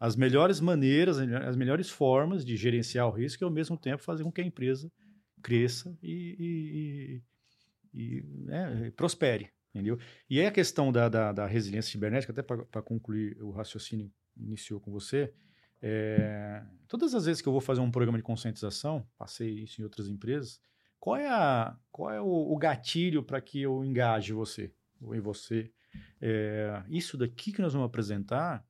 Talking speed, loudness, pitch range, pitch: 180 wpm, -32 LUFS, 110-150 Hz, 120 Hz